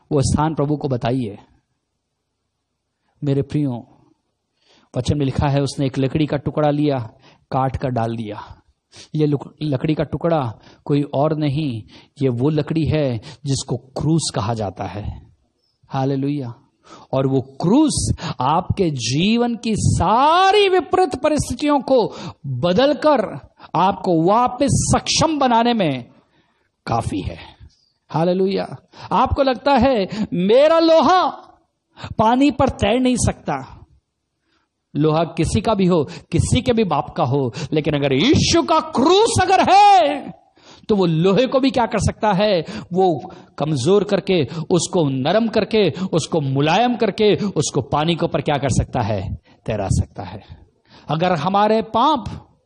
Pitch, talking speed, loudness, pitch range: 155 Hz, 135 wpm, -18 LUFS, 135-220 Hz